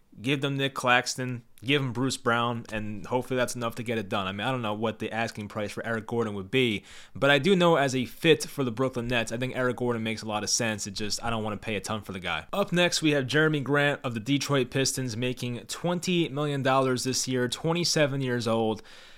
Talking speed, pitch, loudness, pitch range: 255 wpm, 125 Hz, -27 LUFS, 110-140 Hz